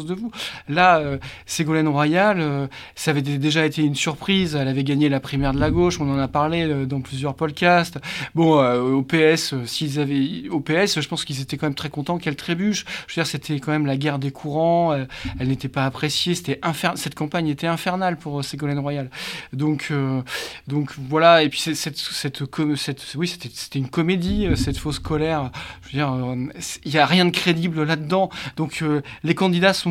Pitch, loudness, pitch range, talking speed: 150 Hz, -21 LUFS, 140-165 Hz, 215 wpm